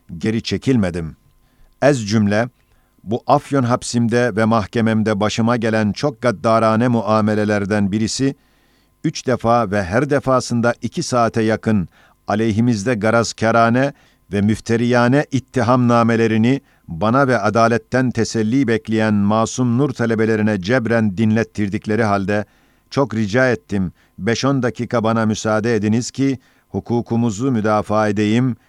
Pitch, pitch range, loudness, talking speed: 115 Hz, 110-125 Hz, -17 LUFS, 110 wpm